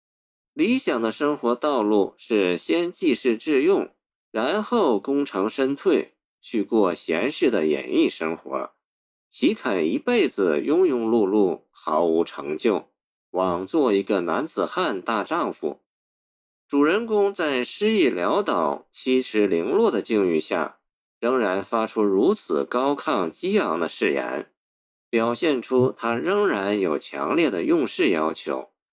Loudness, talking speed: -23 LUFS, 195 characters per minute